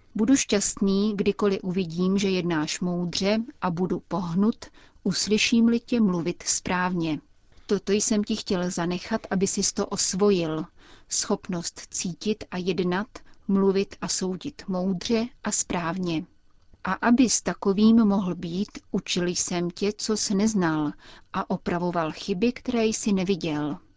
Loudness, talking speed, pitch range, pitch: -25 LUFS, 130 wpm, 175-215 Hz, 195 Hz